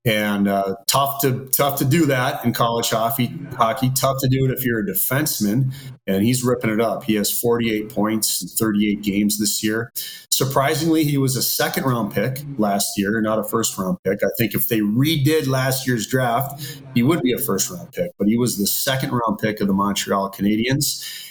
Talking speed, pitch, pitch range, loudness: 210 wpm, 120 Hz, 105-135 Hz, -20 LUFS